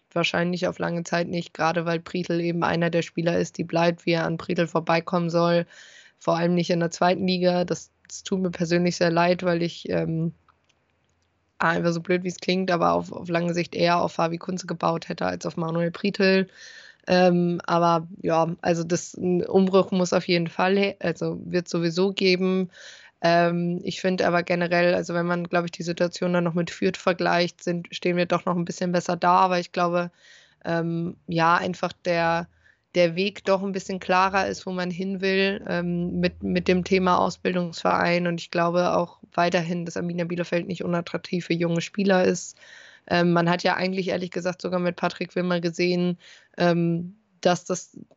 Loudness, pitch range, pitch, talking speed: -24 LUFS, 170-180 Hz, 175 Hz, 190 wpm